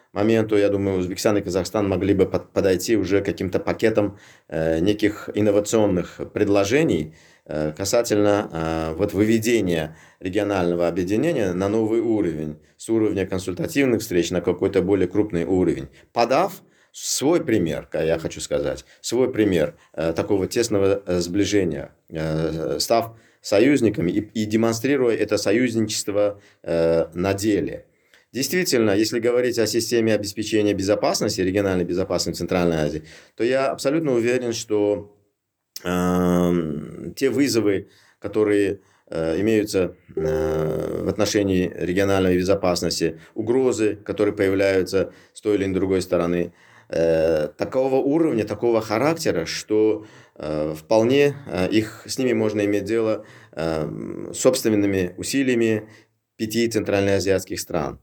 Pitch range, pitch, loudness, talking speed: 90-110 Hz, 100 Hz, -22 LUFS, 120 wpm